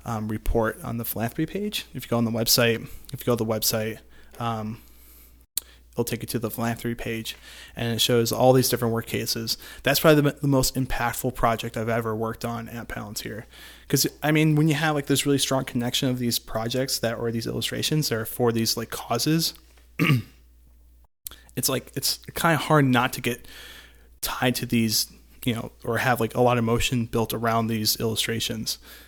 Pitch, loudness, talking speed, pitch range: 115 Hz, -24 LUFS, 200 wpm, 110-130 Hz